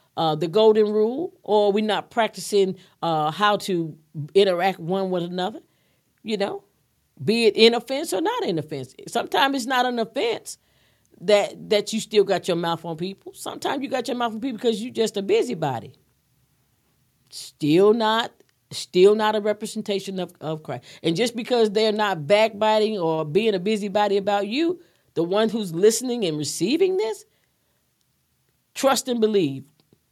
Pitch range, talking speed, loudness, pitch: 175-225 Hz, 165 wpm, -22 LUFS, 205 Hz